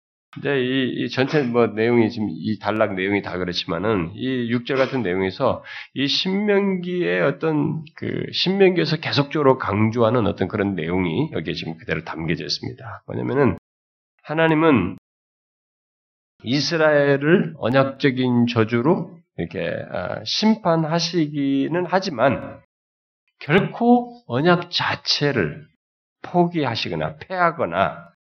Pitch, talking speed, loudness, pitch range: 135 Hz, 260 characters per minute, -21 LUFS, 110-170 Hz